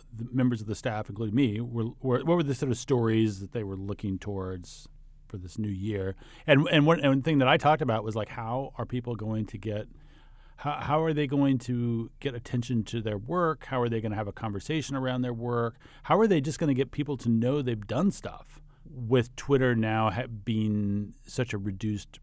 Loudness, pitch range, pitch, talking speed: -28 LUFS, 110-140 Hz, 120 Hz, 225 wpm